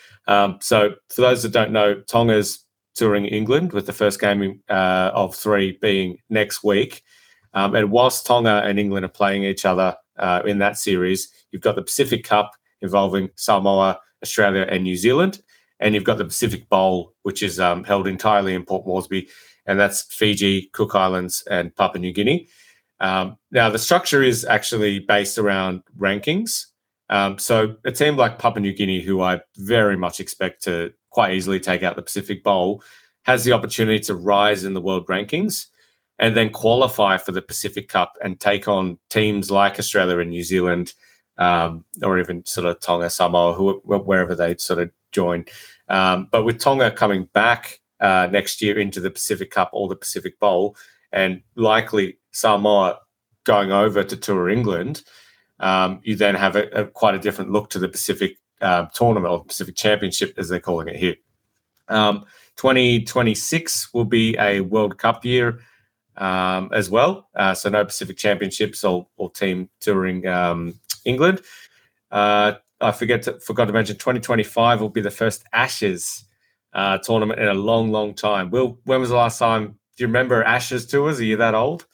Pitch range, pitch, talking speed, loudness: 95-110 Hz, 100 Hz, 180 wpm, -20 LUFS